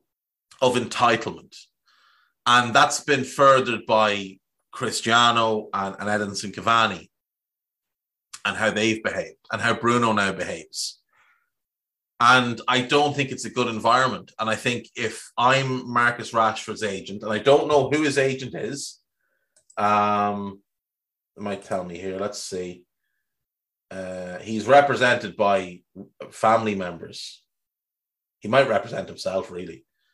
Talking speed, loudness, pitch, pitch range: 125 wpm, -22 LUFS, 115 Hz, 100-125 Hz